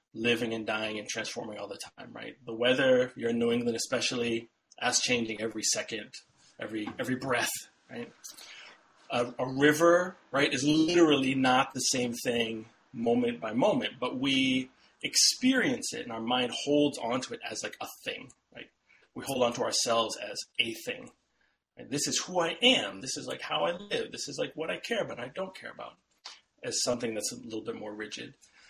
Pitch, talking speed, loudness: 135 Hz, 190 wpm, -29 LUFS